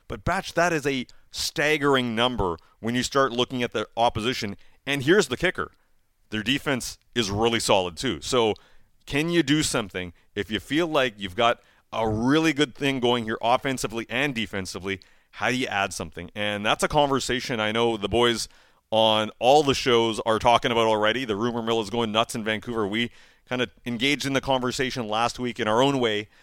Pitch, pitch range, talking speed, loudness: 120 Hz, 110-130 Hz, 195 wpm, -24 LUFS